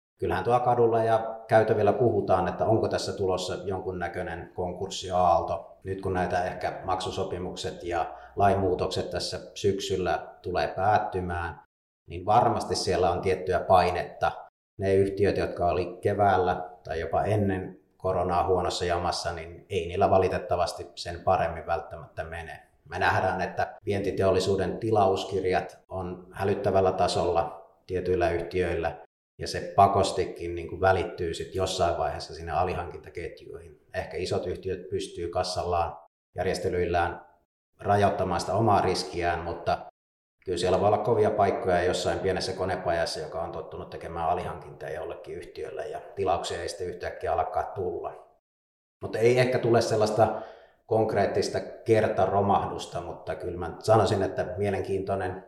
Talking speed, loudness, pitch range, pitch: 125 wpm, -27 LUFS, 90-120 Hz, 100 Hz